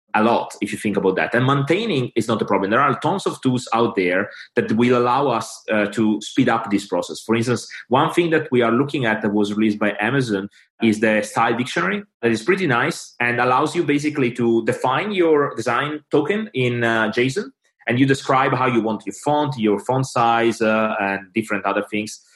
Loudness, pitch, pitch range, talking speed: -20 LUFS, 120 Hz, 110-140 Hz, 215 wpm